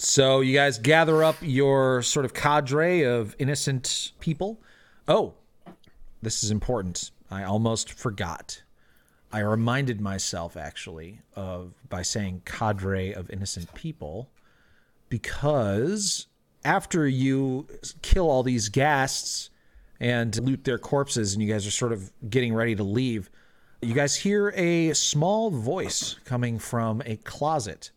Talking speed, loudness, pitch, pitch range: 130 wpm, -25 LUFS, 120 Hz, 105-145 Hz